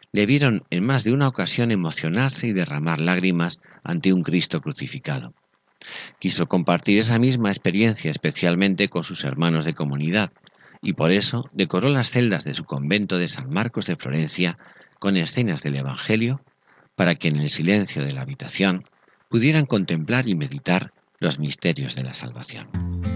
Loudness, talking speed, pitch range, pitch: -22 LUFS, 160 wpm, 85-120 Hz, 95 Hz